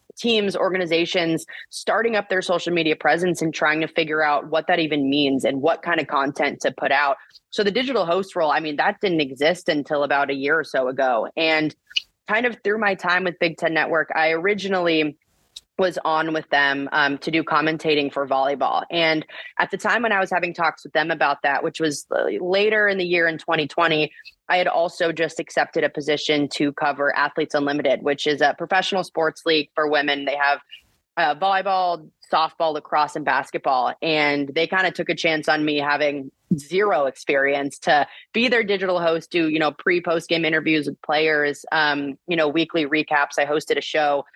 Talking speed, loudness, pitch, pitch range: 195 wpm, -21 LUFS, 160 Hz, 150-175 Hz